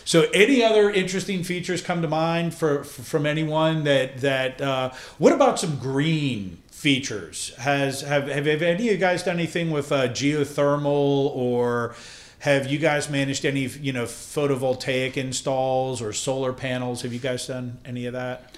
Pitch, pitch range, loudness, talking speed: 140 Hz, 130-160 Hz, -23 LUFS, 170 wpm